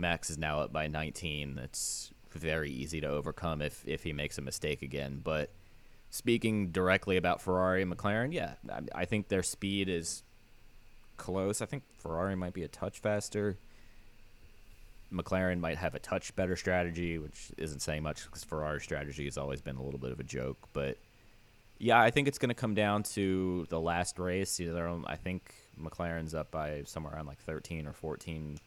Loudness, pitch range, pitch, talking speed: -35 LUFS, 75-105 Hz, 90 Hz, 185 wpm